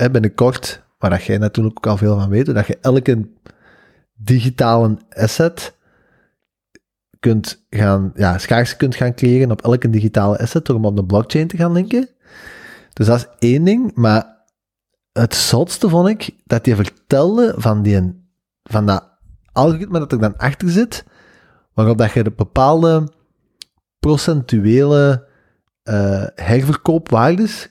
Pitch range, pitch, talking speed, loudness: 110-155 Hz, 120 Hz, 140 wpm, -16 LUFS